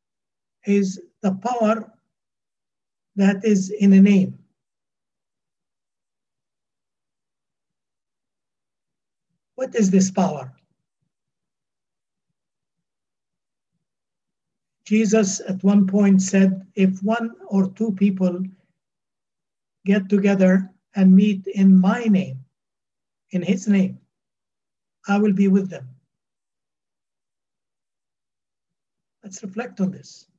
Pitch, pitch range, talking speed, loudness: 195 Hz, 185-205 Hz, 80 wpm, -19 LUFS